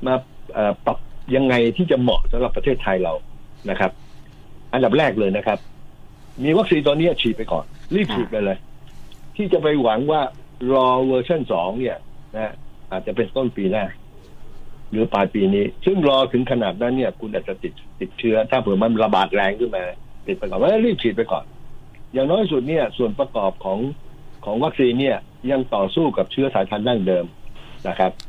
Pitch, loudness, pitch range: 125 Hz, -20 LUFS, 105-135 Hz